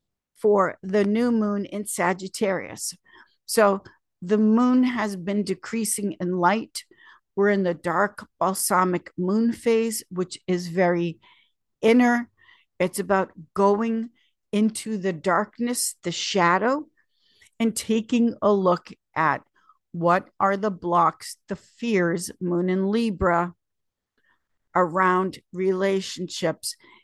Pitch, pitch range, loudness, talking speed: 200 Hz, 180-225 Hz, -24 LUFS, 110 wpm